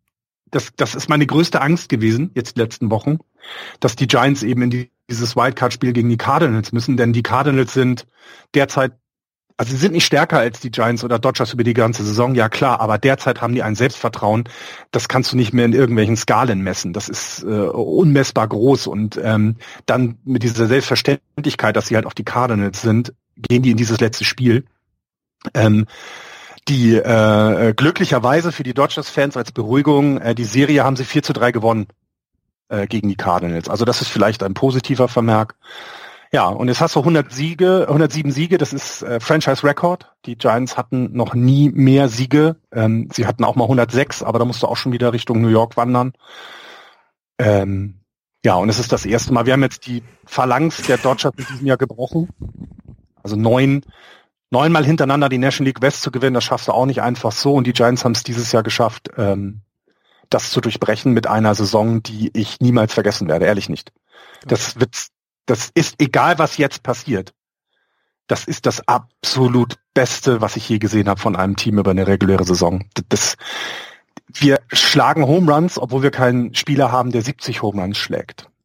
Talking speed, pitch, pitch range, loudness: 190 wpm, 125 Hz, 115-135 Hz, -17 LUFS